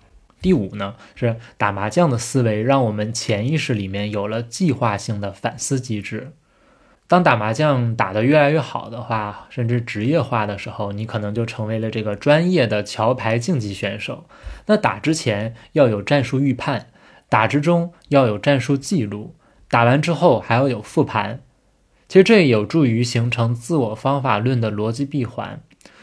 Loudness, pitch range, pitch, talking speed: -19 LUFS, 110-145 Hz, 120 Hz, 260 characters per minute